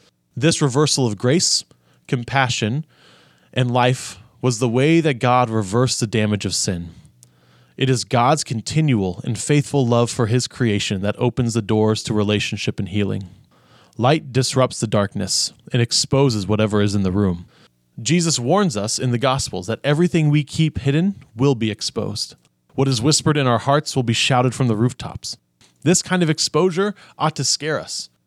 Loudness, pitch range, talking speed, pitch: -19 LUFS, 105-140 Hz, 170 wpm, 125 Hz